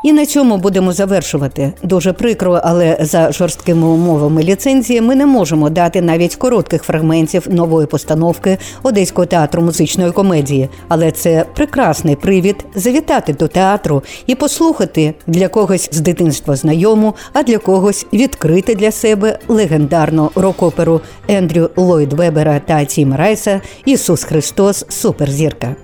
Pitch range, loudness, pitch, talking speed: 160-210 Hz, -12 LUFS, 175 Hz, 130 wpm